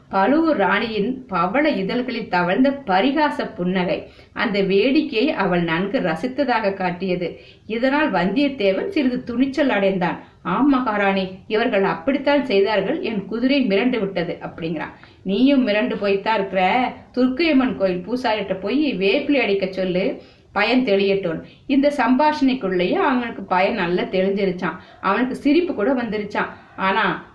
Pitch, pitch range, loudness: 215 Hz, 190-260 Hz, -20 LUFS